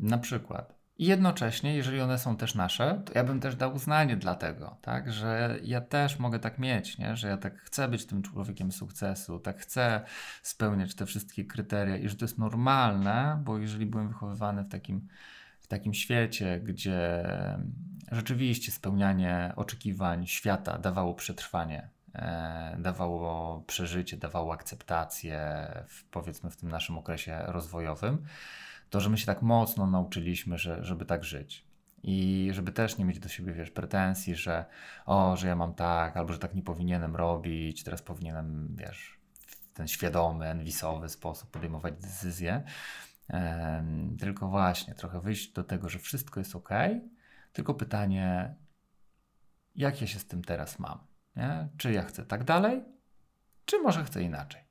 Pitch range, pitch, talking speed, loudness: 85-115 Hz, 95 Hz, 160 wpm, -32 LUFS